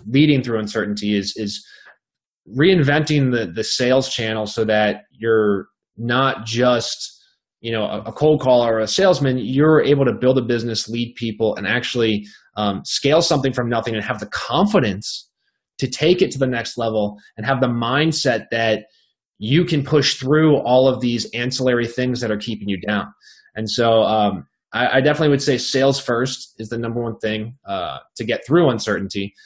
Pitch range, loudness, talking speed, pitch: 110-135 Hz, -19 LUFS, 180 wpm, 120 Hz